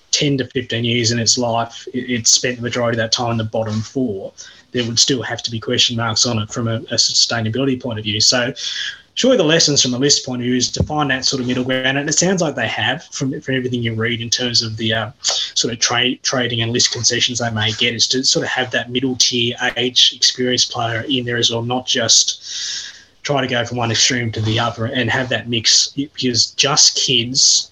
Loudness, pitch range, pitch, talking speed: -16 LUFS, 115-130 Hz, 120 Hz, 245 wpm